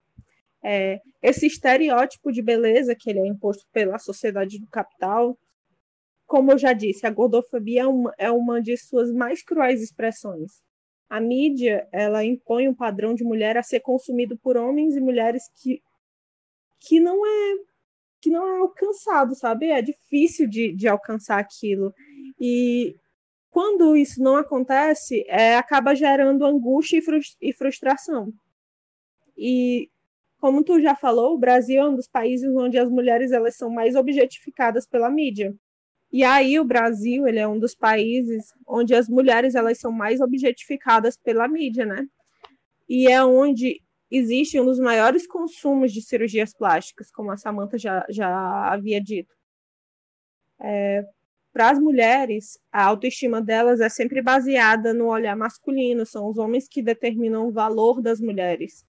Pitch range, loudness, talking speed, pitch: 225-270 Hz, -21 LUFS, 150 wpm, 245 Hz